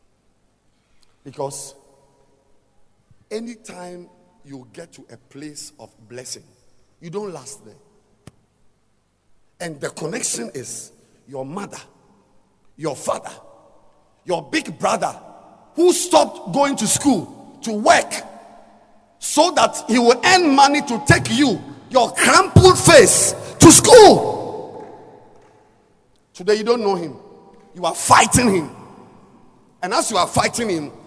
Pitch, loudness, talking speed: 180 Hz, -15 LUFS, 115 wpm